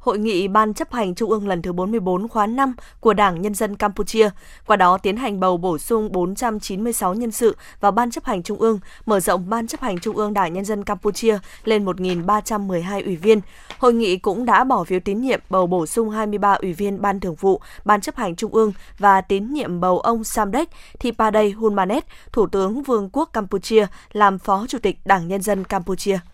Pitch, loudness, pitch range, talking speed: 210 Hz, -20 LUFS, 190-225 Hz, 205 wpm